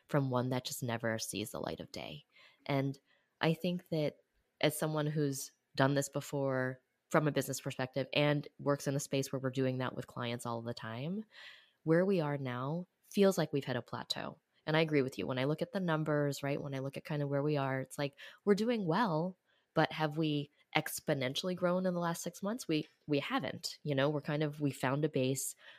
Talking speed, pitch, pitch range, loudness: 225 wpm, 145 Hz, 135-160 Hz, -35 LUFS